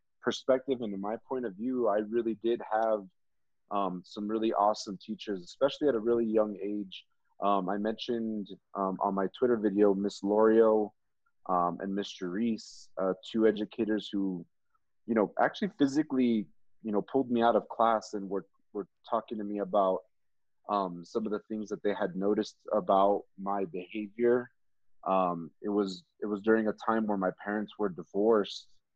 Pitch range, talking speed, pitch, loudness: 100-110 Hz, 170 wpm, 105 Hz, -31 LUFS